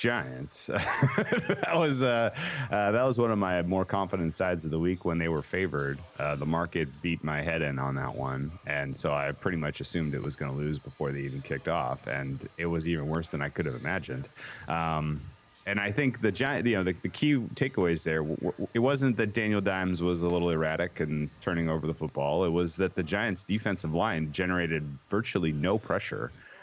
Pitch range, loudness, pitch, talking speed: 75-100 Hz, -30 LUFS, 85 Hz, 215 wpm